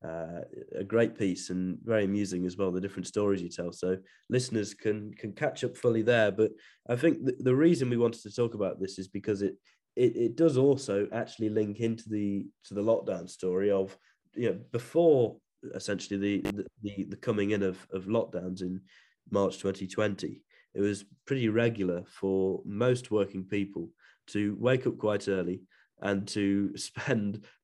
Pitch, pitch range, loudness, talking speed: 100 Hz, 95-115 Hz, -30 LUFS, 180 wpm